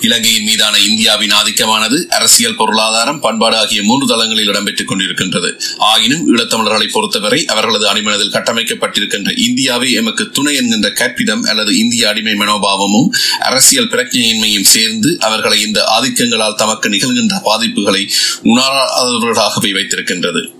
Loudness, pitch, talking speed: -10 LUFS, 225 Hz, 110 wpm